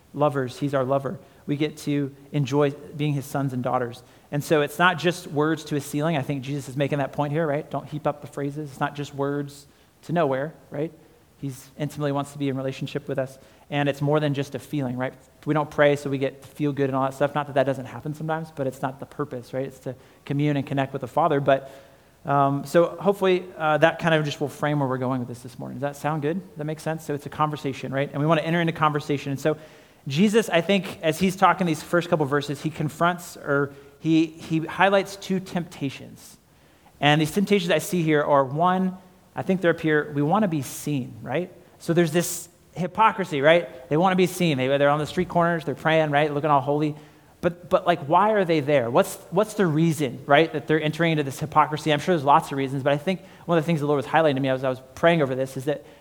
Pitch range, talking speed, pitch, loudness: 140-165 Hz, 255 wpm, 150 Hz, -24 LUFS